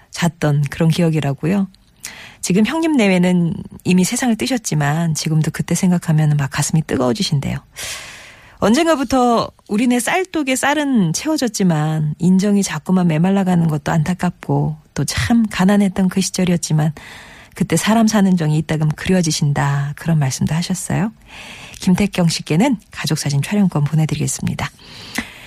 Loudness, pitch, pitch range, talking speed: -17 LUFS, 175 Hz, 155-200 Hz, 330 characters per minute